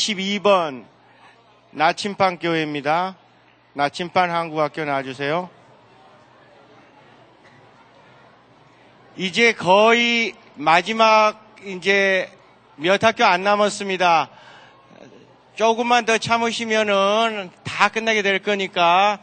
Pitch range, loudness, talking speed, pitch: 170-215 Hz, -19 LUFS, 175 characters per minute, 195 Hz